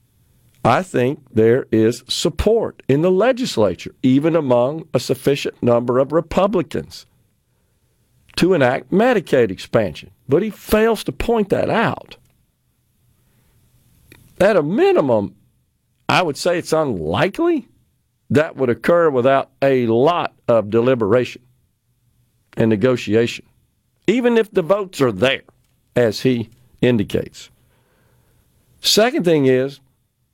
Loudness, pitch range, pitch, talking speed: -17 LUFS, 120-175 Hz, 130 Hz, 110 wpm